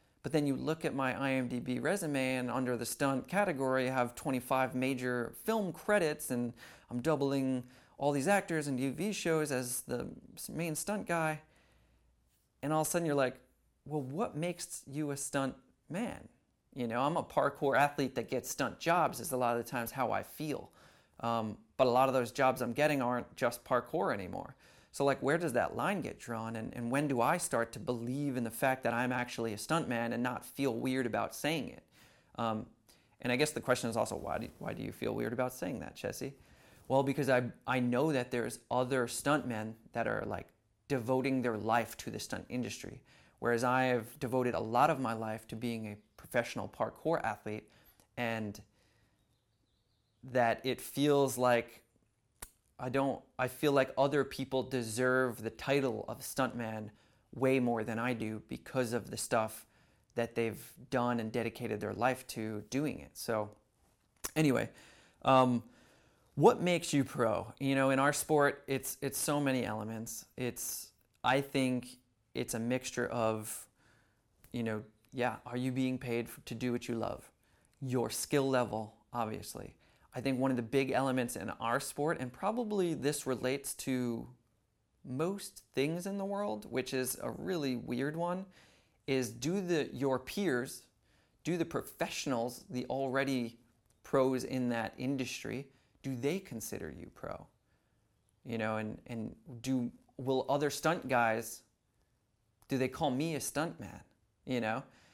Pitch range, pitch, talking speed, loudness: 115-135 Hz, 125 Hz, 170 wpm, -35 LUFS